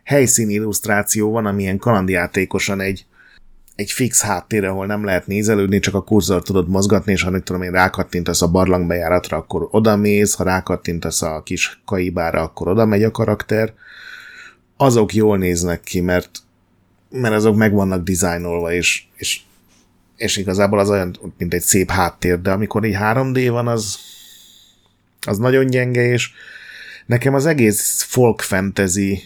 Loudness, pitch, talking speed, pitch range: -17 LUFS, 100 Hz, 150 wpm, 90-110 Hz